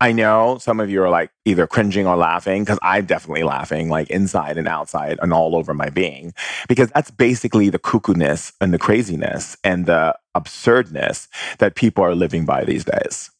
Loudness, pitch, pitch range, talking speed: -18 LUFS, 100 Hz, 85-115 Hz, 195 wpm